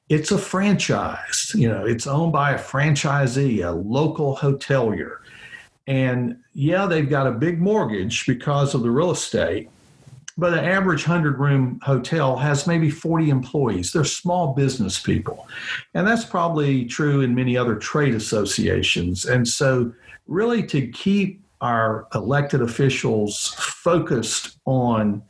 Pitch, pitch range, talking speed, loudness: 140 Hz, 125-165 Hz, 140 wpm, -21 LUFS